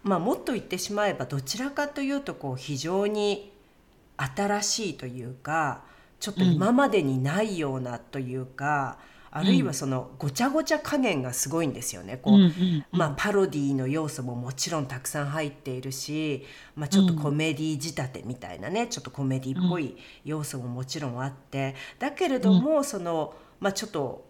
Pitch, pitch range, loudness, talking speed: 155 Hz, 135-200 Hz, -27 LUFS, 375 characters per minute